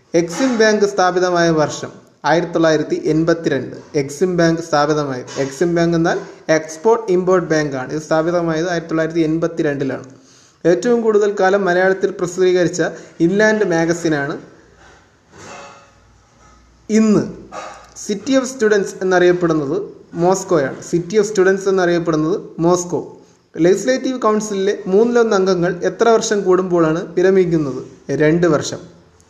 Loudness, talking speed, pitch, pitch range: -16 LUFS, 100 wpm, 175 Hz, 160-195 Hz